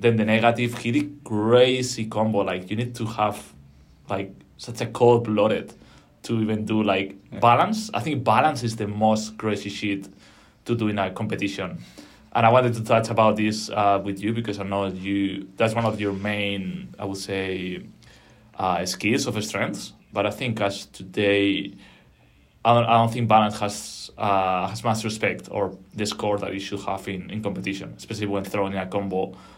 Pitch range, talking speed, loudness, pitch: 100-115 Hz, 185 wpm, -24 LUFS, 105 Hz